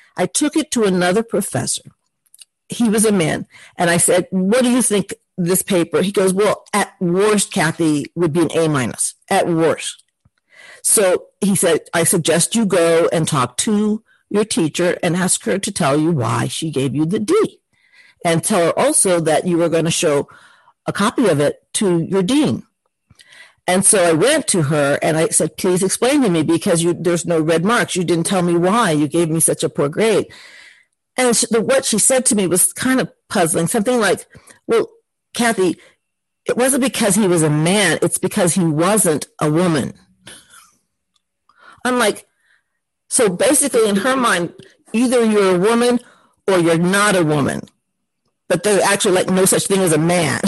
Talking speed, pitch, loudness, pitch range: 190 wpm, 185 Hz, -16 LUFS, 170-225 Hz